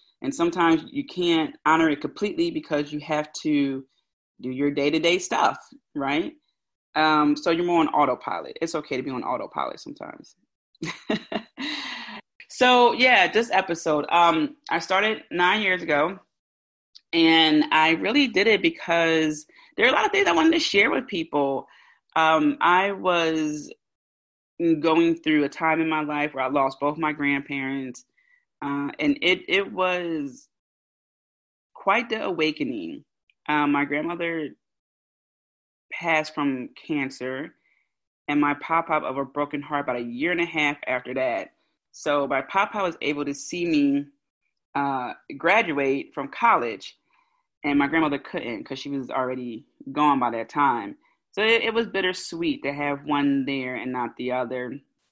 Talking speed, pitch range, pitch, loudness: 155 wpm, 140-190 Hz, 155 Hz, -23 LUFS